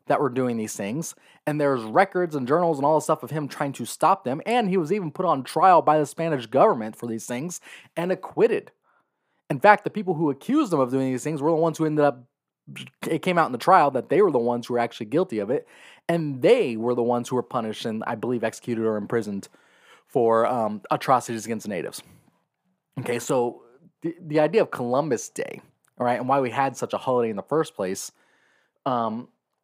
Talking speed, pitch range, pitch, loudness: 225 wpm, 120-165 Hz, 135 Hz, -24 LUFS